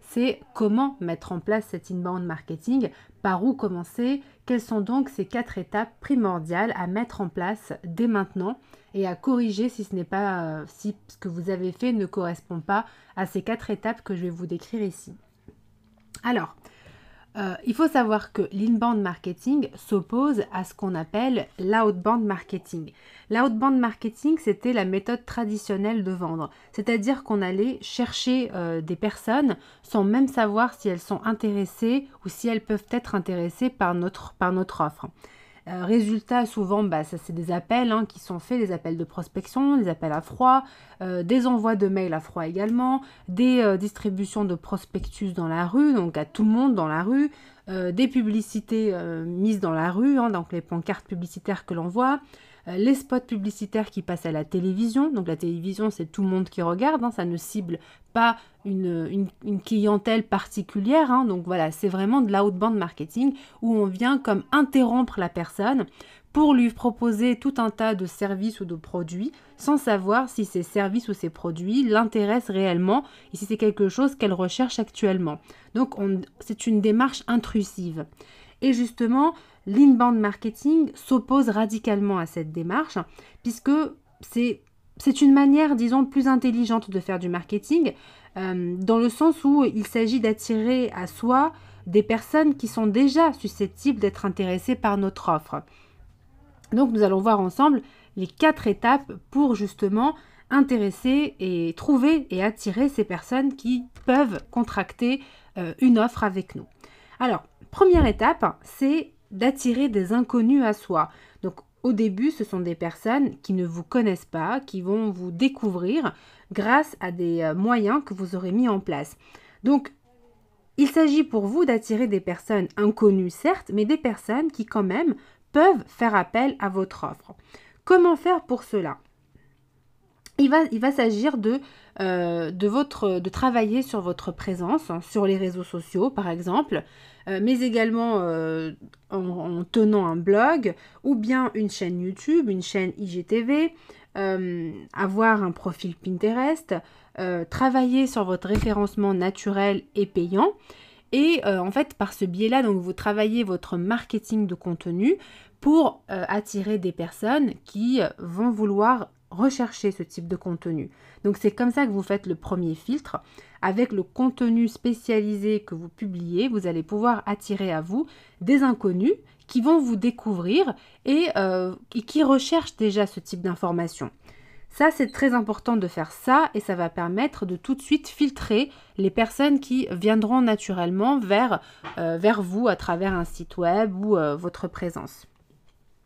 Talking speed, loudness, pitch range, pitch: 165 wpm, -24 LUFS, 185-245 Hz, 210 Hz